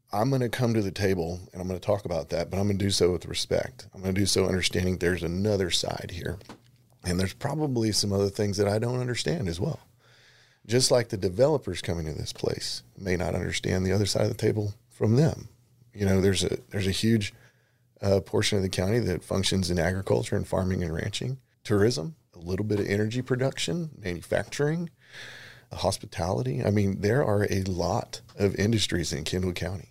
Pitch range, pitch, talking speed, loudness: 95-120 Hz, 100 Hz, 205 wpm, -27 LUFS